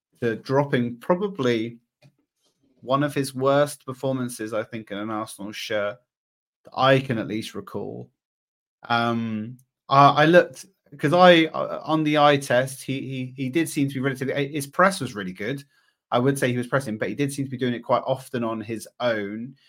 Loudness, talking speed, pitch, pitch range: -23 LUFS, 190 wpm, 130 Hz, 115-140 Hz